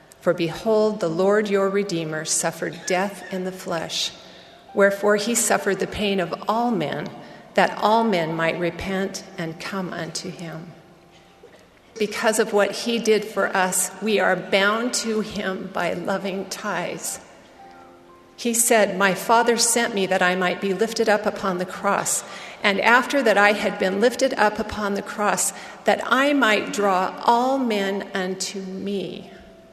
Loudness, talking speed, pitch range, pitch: -22 LUFS, 155 wpm, 180-215 Hz, 195 Hz